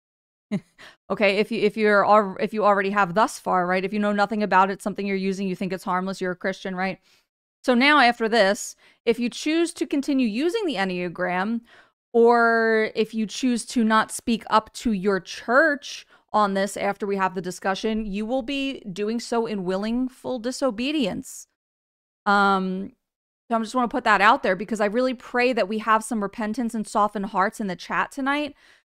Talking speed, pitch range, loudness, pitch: 195 wpm, 195-240 Hz, -23 LUFS, 215 Hz